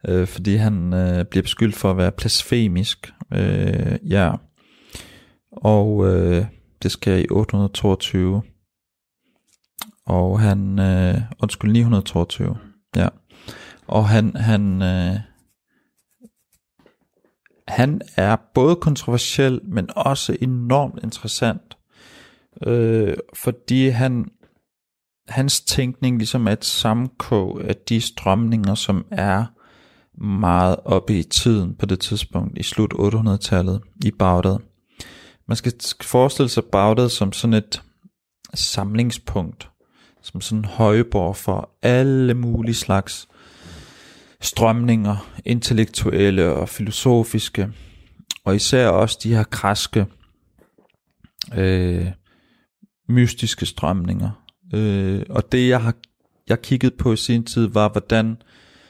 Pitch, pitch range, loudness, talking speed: 105 Hz, 95-115 Hz, -20 LUFS, 105 wpm